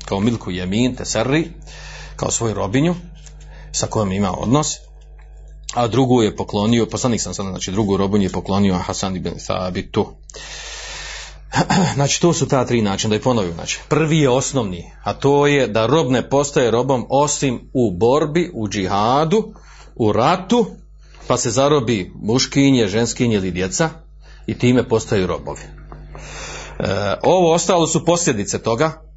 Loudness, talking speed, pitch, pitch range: -18 LUFS, 145 wpm, 120 Hz, 100-155 Hz